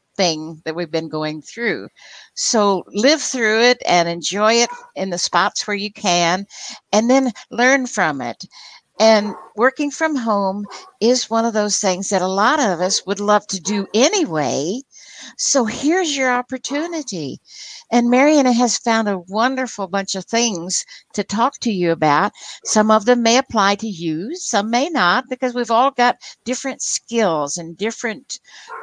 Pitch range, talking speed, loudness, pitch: 195-255 Hz, 165 wpm, -18 LUFS, 220 Hz